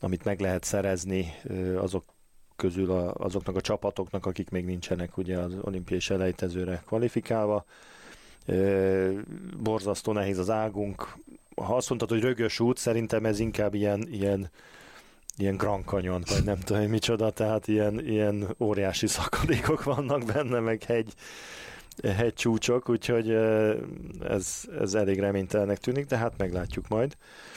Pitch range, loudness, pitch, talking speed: 95-110 Hz, -29 LUFS, 105 Hz, 135 wpm